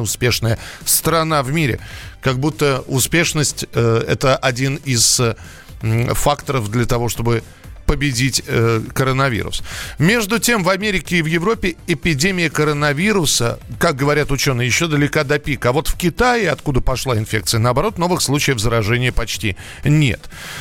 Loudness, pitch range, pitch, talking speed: -17 LUFS, 115-160 Hz, 135 Hz, 140 wpm